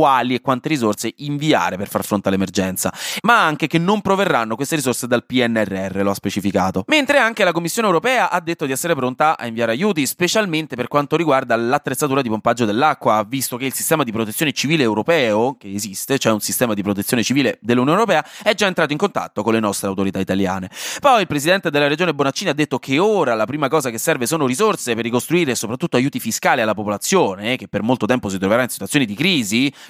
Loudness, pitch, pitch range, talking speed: -18 LUFS, 125 Hz, 105-160 Hz, 210 wpm